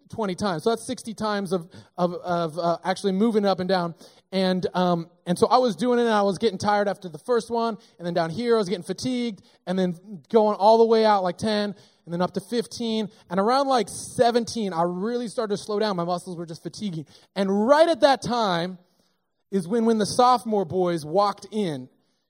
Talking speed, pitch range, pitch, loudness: 220 wpm, 180-230 Hz, 200 Hz, -24 LUFS